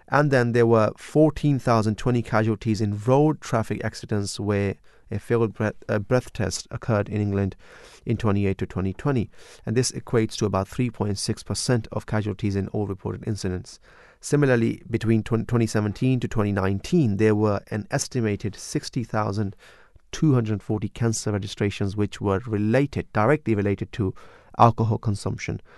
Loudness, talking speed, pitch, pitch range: -24 LUFS, 135 wpm, 110 Hz, 100-120 Hz